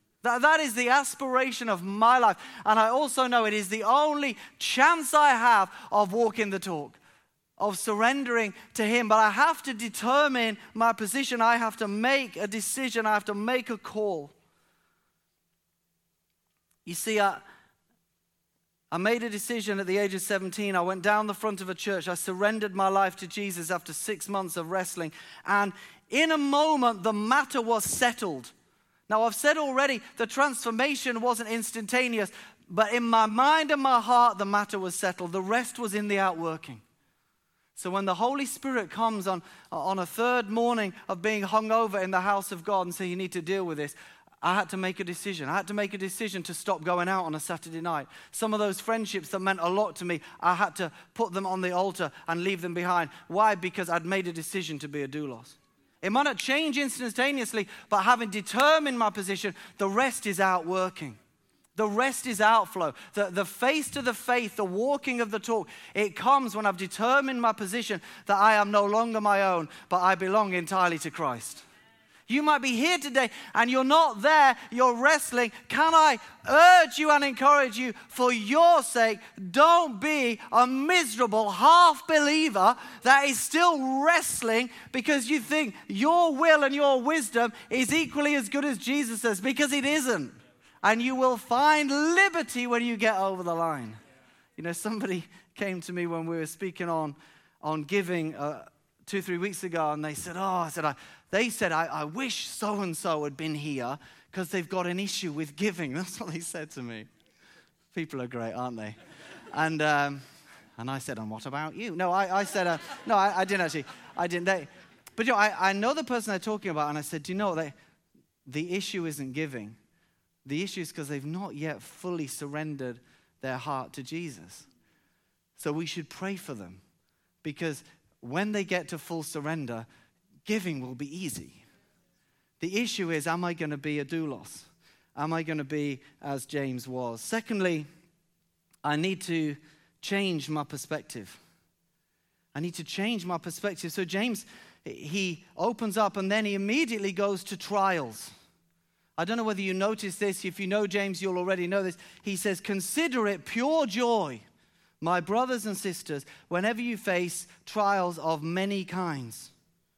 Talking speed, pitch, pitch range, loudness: 190 wpm, 200 Hz, 170-235 Hz, -27 LUFS